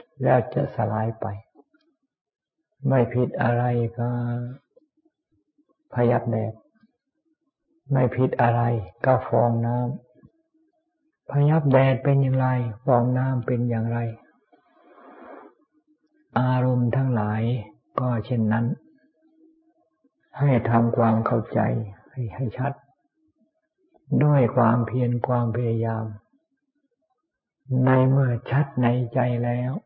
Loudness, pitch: -23 LUFS, 130 Hz